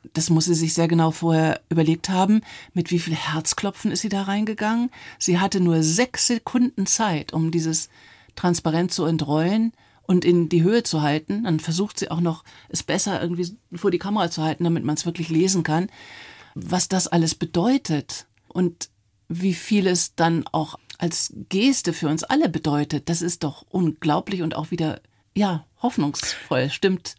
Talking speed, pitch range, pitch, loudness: 175 wpm, 160-195 Hz, 170 Hz, -22 LUFS